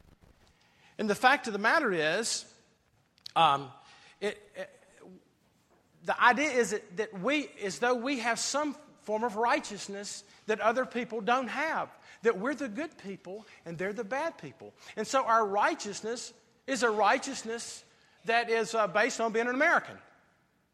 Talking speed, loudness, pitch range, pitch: 155 wpm, -30 LUFS, 205-260 Hz, 230 Hz